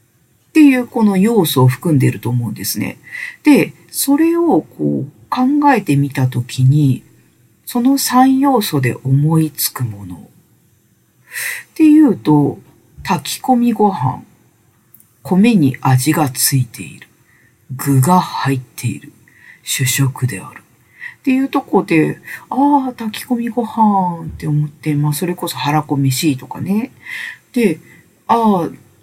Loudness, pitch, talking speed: -15 LUFS, 160 Hz, 235 characters per minute